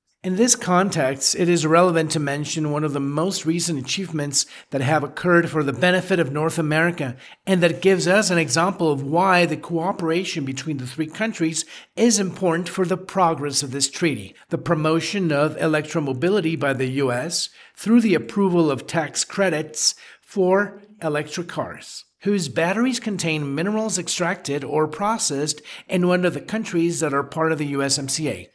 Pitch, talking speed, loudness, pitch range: 165 Hz, 165 wpm, -21 LUFS, 150-180 Hz